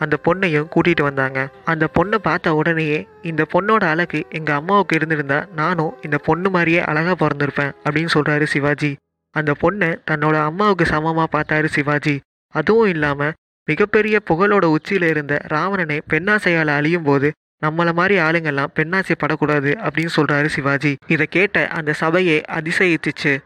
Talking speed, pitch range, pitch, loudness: 135 wpm, 150-170 Hz, 155 Hz, -18 LUFS